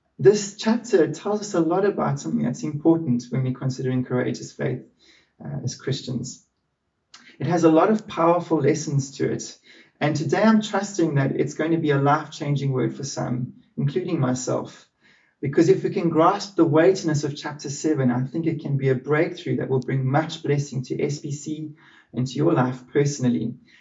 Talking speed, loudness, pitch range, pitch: 185 wpm, -23 LUFS, 135-170 Hz, 150 Hz